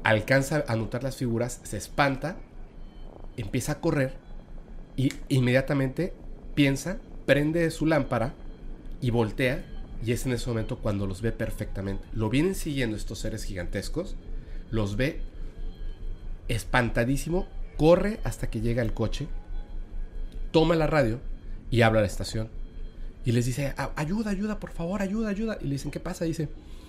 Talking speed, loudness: 150 wpm, -28 LUFS